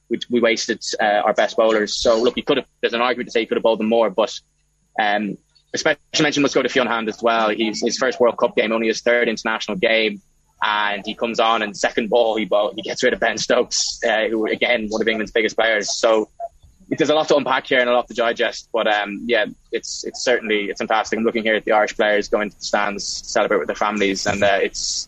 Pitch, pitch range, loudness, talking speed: 110 Hz, 105-120 Hz, -19 LUFS, 255 wpm